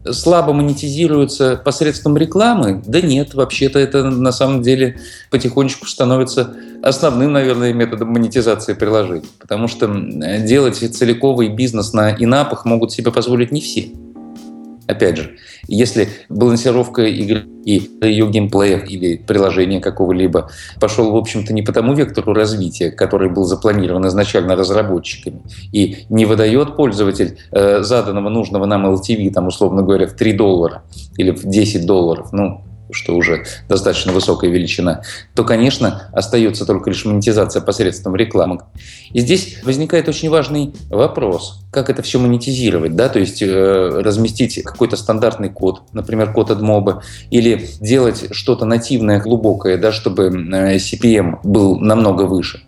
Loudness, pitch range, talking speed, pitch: -15 LUFS, 95-125 Hz, 135 wpm, 110 Hz